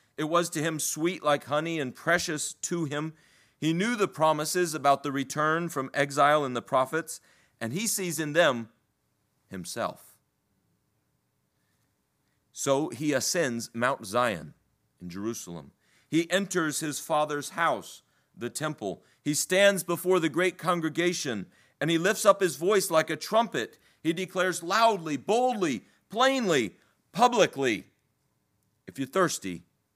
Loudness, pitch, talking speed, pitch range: -27 LUFS, 155 Hz, 135 wpm, 140-180 Hz